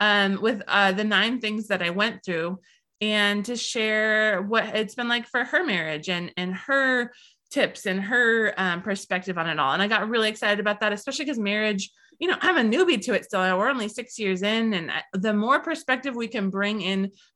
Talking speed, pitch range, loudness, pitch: 210 wpm, 195-240 Hz, -24 LUFS, 215 Hz